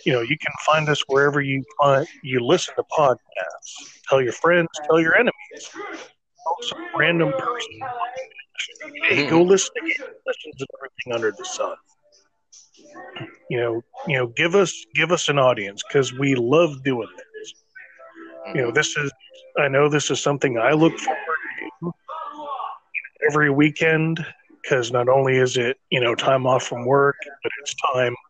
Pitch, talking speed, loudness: 155 Hz, 165 wpm, -21 LUFS